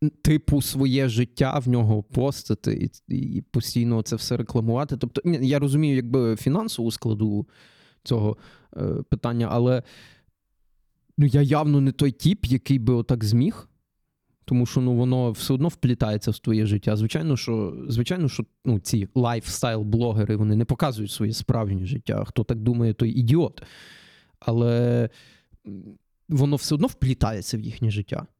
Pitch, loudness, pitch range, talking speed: 120 Hz, -24 LUFS, 115-135 Hz, 145 wpm